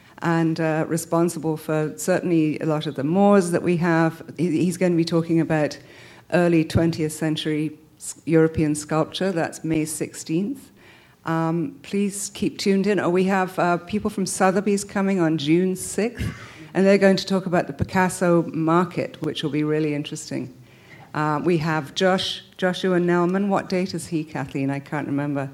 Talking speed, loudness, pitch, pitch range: 165 wpm, -22 LUFS, 165 Hz, 155-185 Hz